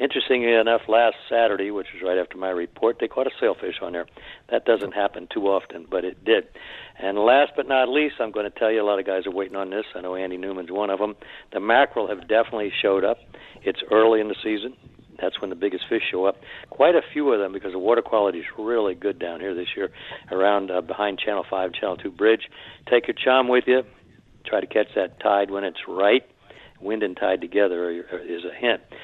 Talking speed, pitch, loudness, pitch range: 230 wpm, 105 Hz, -23 LUFS, 95-115 Hz